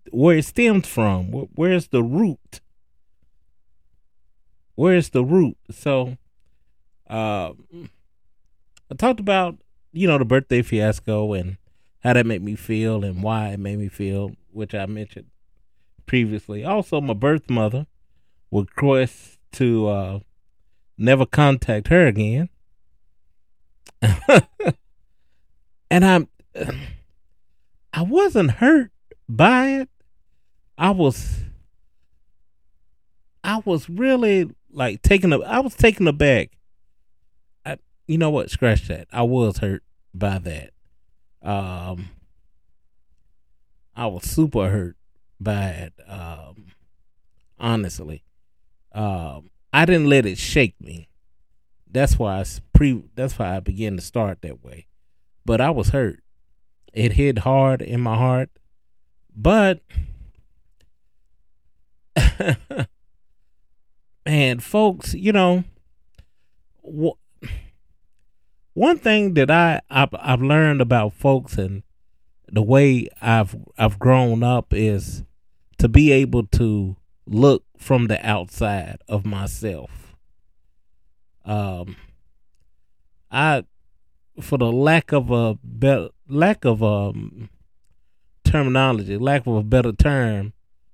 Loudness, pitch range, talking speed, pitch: -20 LUFS, 80-130 Hz, 110 wpm, 105 Hz